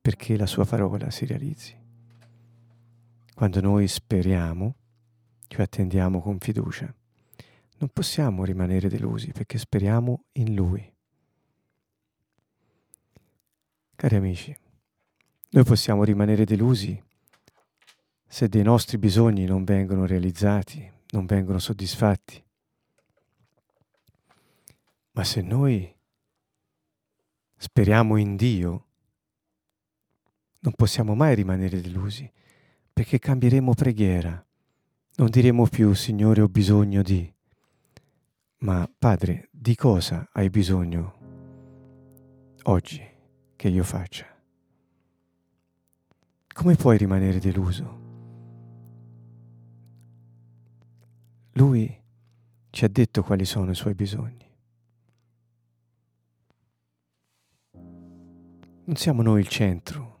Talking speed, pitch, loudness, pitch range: 85 wpm, 110 Hz, -23 LUFS, 95-120 Hz